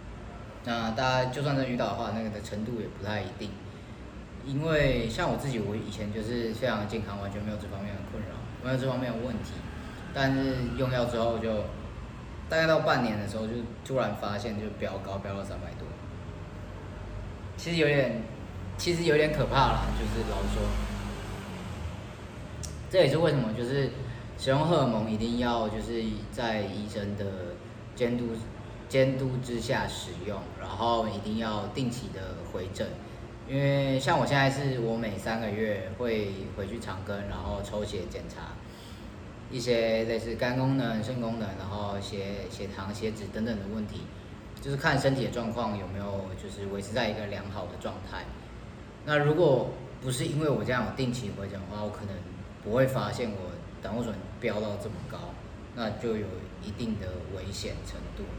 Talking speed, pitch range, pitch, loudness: 255 characters per minute, 100-120 Hz, 110 Hz, -31 LUFS